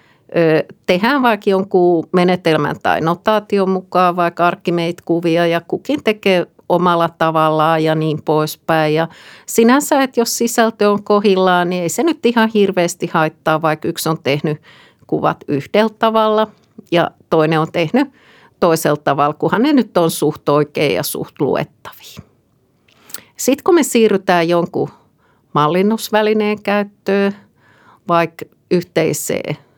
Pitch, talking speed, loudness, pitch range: 175 Hz, 125 wpm, -15 LUFS, 160-215 Hz